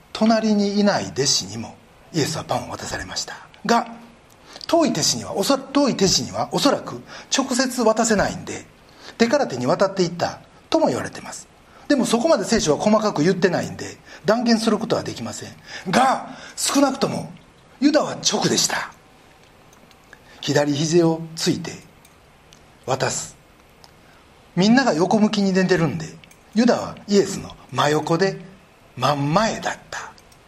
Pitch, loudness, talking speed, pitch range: 205 Hz, -20 LUFS, 295 characters per minute, 165-230 Hz